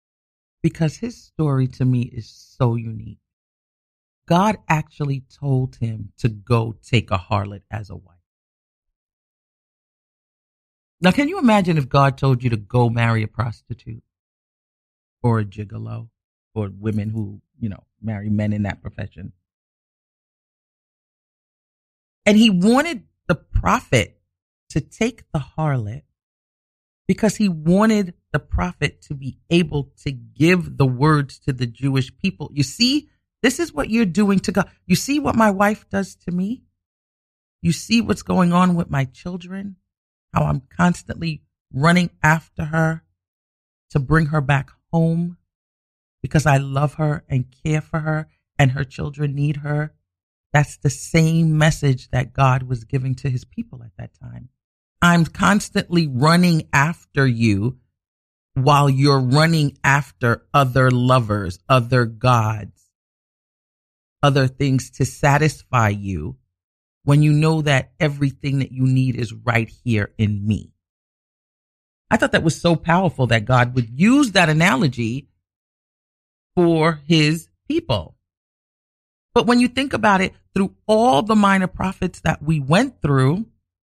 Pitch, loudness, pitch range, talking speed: 135 Hz, -19 LUFS, 110-165 Hz, 140 wpm